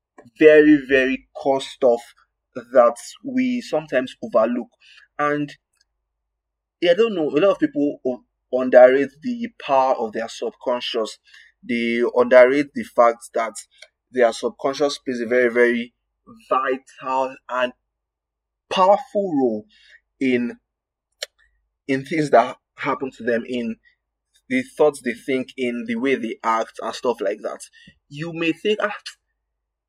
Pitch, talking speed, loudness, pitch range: 130 Hz, 125 wpm, -20 LUFS, 120-155 Hz